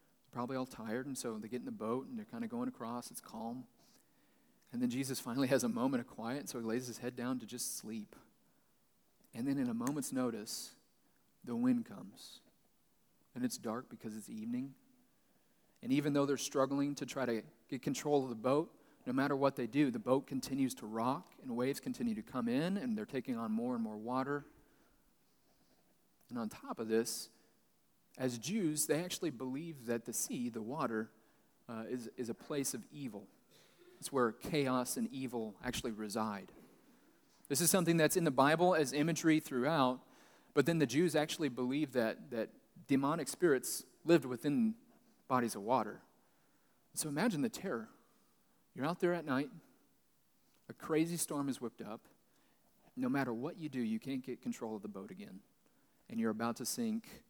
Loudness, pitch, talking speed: -37 LUFS, 140 Hz, 185 wpm